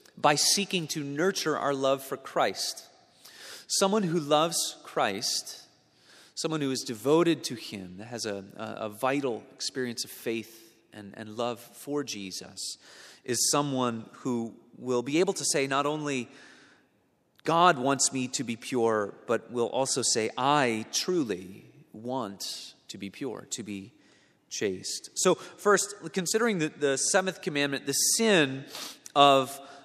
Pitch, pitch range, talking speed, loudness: 135 Hz, 115-155 Hz, 140 wpm, -28 LUFS